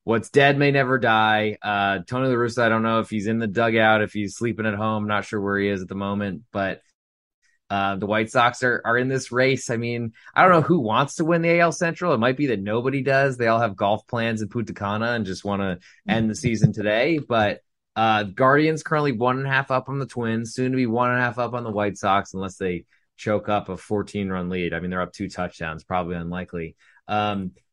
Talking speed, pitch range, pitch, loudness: 245 wpm, 100-125 Hz, 110 Hz, -22 LUFS